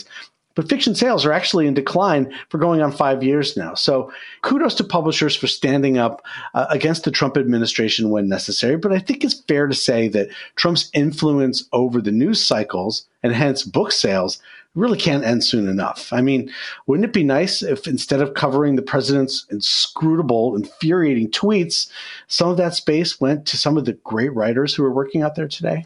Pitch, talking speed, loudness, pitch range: 145 Hz, 190 wpm, -18 LUFS, 130-170 Hz